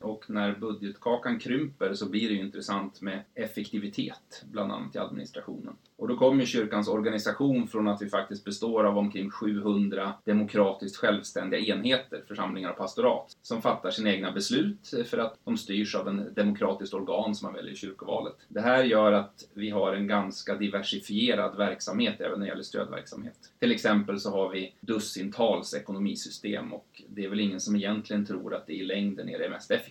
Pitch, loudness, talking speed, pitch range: 105 Hz, -30 LUFS, 185 wpm, 100-105 Hz